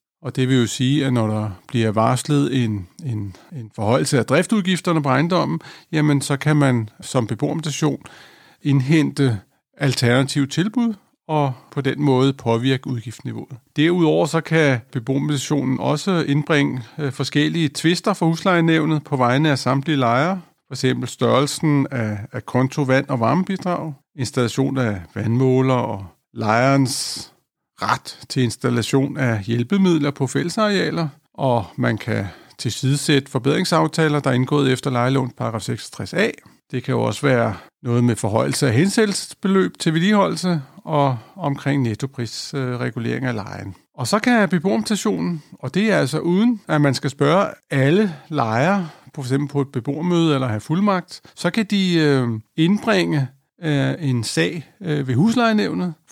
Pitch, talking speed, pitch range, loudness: 140 Hz, 135 wpm, 125-160 Hz, -20 LUFS